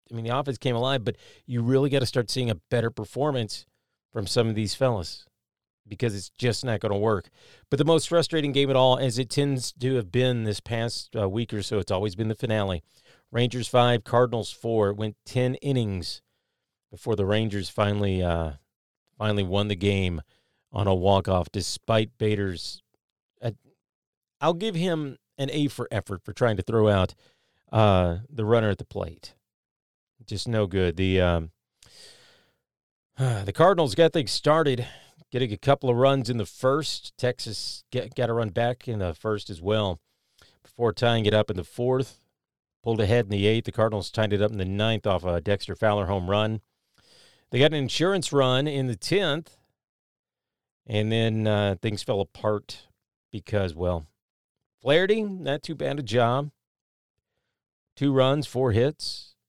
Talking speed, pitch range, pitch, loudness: 180 wpm, 100-130 Hz, 115 Hz, -25 LUFS